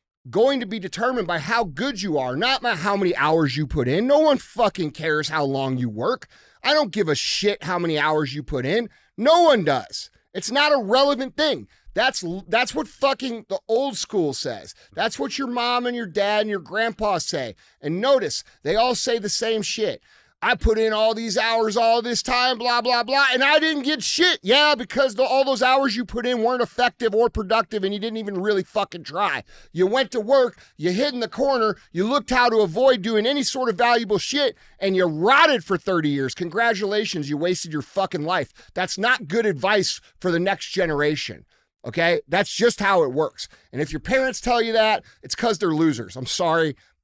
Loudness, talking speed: -21 LUFS, 215 wpm